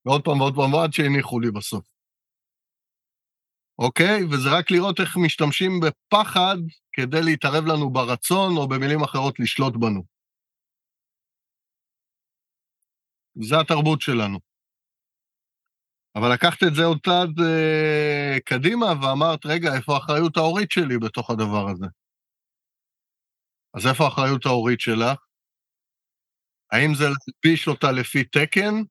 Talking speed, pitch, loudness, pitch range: 110 wpm, 150 Hz, -21 LUFS, 125-165 Hz